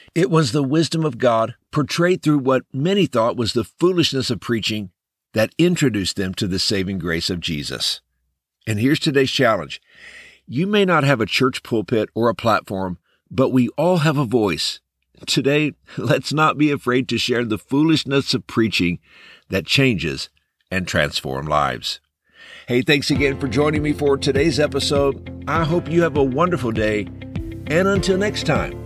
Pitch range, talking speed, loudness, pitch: 110-150 Hz, 170 wpm, -19 LUFS, 135 Hz